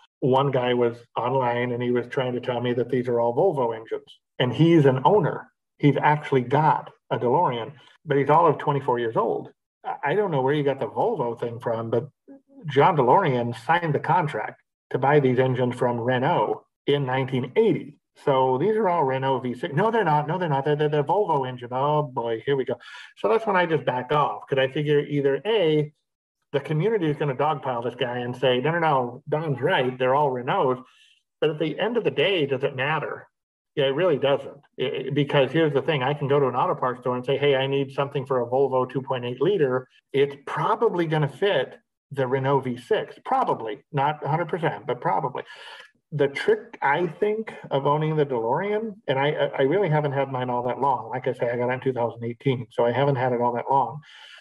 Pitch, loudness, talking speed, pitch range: 140 Hz, -24 LUFS, 215 wpm, 125-150 Hz